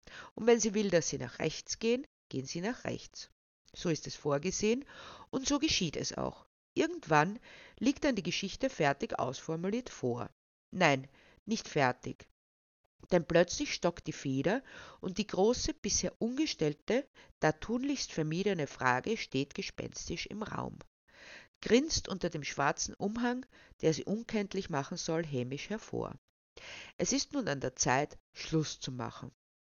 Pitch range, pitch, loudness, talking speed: 150-235 Hz, 185 Hz, -34 LUFS, 145 wpm